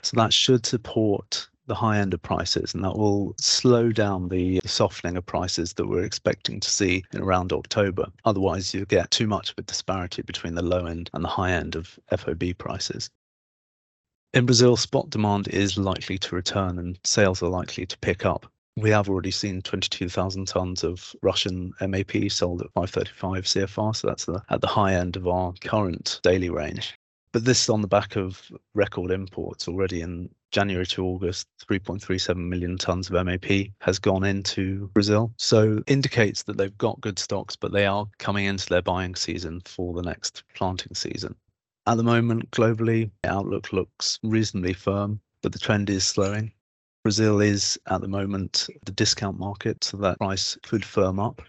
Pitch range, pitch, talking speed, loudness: 90-105 Hz, 95 Hz, 180 wpm, -25 LUFS